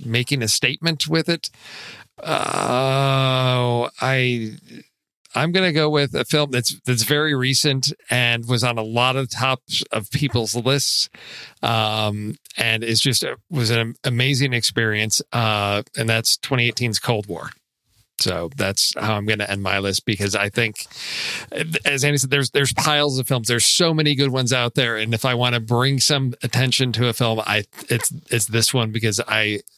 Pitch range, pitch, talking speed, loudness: 115-140 Hz, 125 Hz, 175 wpm, -19 LUFS